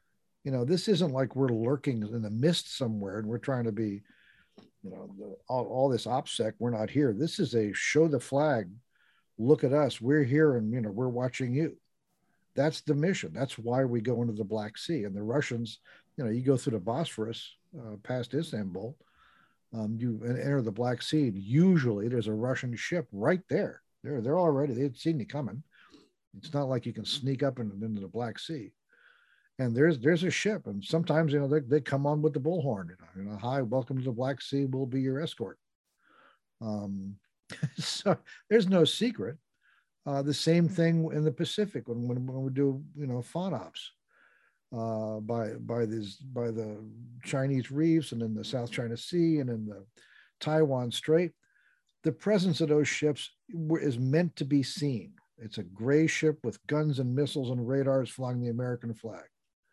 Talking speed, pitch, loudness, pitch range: 195 wpm, 135 Hz, -30 LUFS, 115-155 Hz